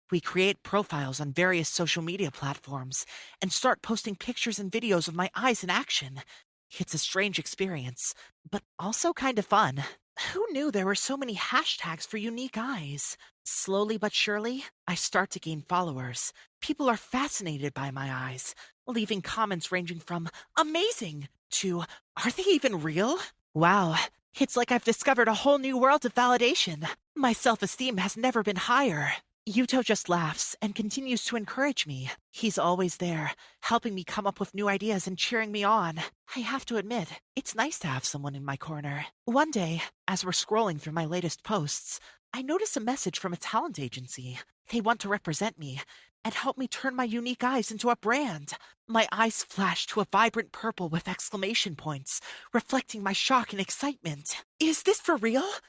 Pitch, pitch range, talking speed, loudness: 205 Hz, 170-240 Hz, 180 wpm, -29 LUFS